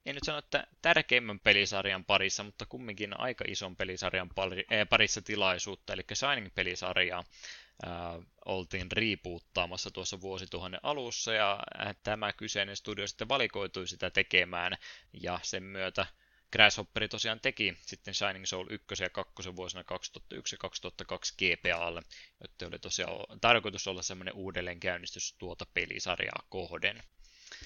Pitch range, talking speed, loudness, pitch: 90-105 Hz, 115 wpm, -32 LUFS, 95 Hz